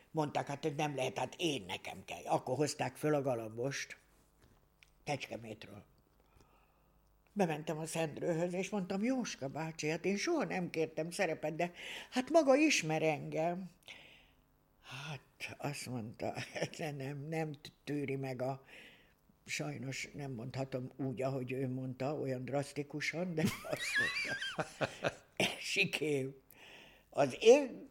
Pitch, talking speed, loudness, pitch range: 150 Hz, 120 wpm, -37 LUFS, 135-175 Hz